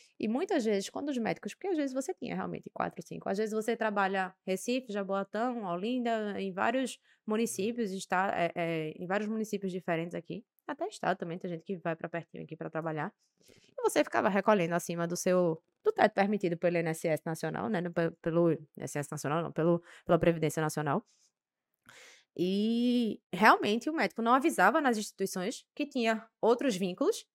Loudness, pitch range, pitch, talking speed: -32 LUFS, 170-230 Hz, 195 Hz, 170 wpm